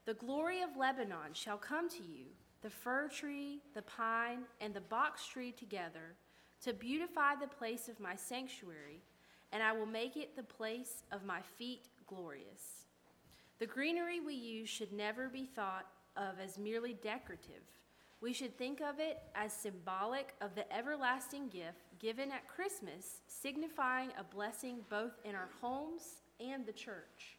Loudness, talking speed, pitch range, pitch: -43 LUFS, 160 wpm, 205-265 Hz, 235 Hz